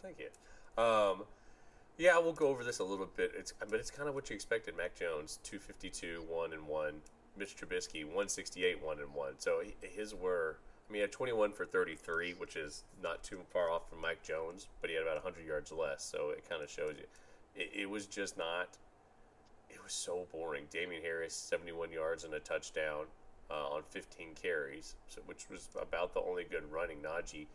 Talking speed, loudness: 215 wpm, -39 LUFS